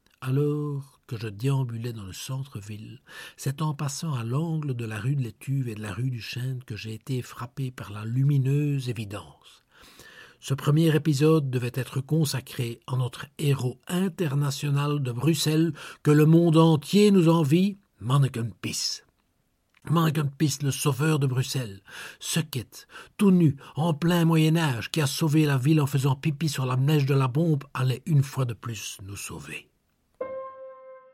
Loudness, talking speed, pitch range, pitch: -25 LUFS, 160 wpm, 125-155 Hz, 140 Hz